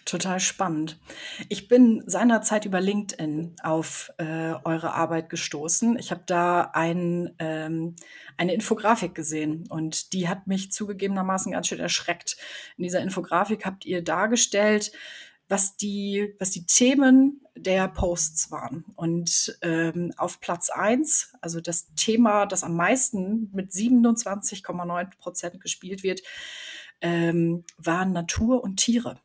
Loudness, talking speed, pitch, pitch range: -24 LUFS, 130 wpm, 185 Hz, 170-215 Hz